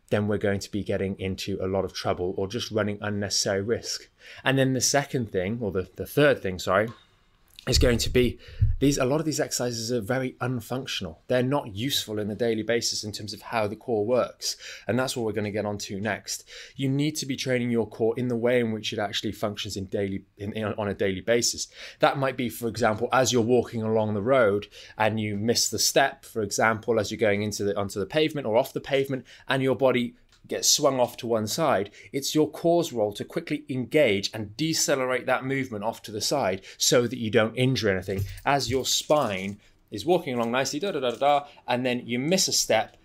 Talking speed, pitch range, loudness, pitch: 230 wpm, 105-130 Hz, -26 LUFS, 115 Hz